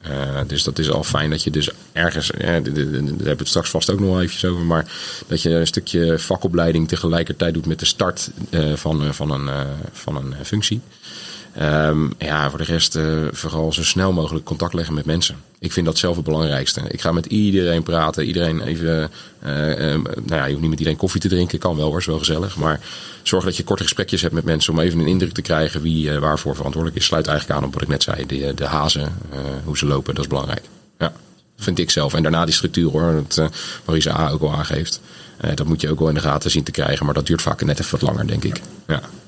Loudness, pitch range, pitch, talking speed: -20 LUFS, 75-85 Hz, 80 Hz, 250 wpm